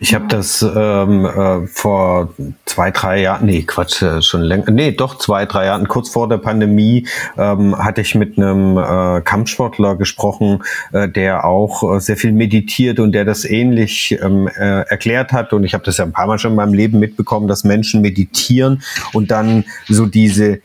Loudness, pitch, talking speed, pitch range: -14 LUFS, 105 Hz, 185 wpm, 95-110 Hz